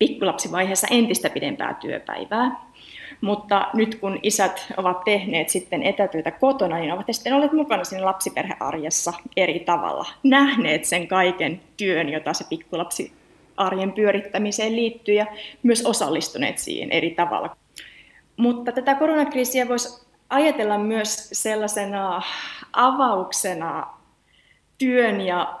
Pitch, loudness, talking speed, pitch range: 205 Hz, -22 LUFS, 110 wpm, 180-240 Hz